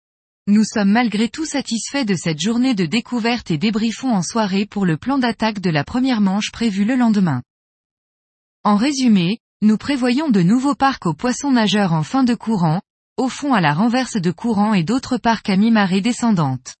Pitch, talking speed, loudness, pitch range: 220 Hz, 185 wpm, -18 LUFS, 195-245 Hz